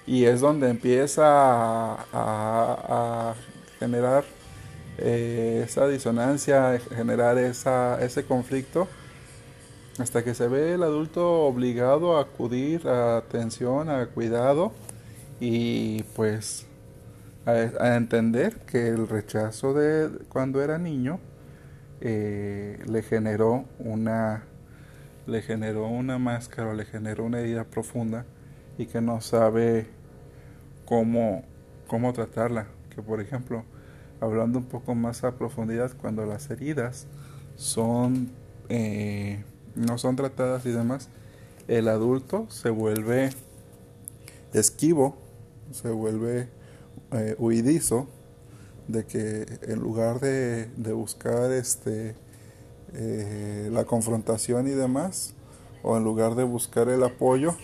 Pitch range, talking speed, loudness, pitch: 115-130 Hz, 115 wpm, -26 LUFS, 120 Hz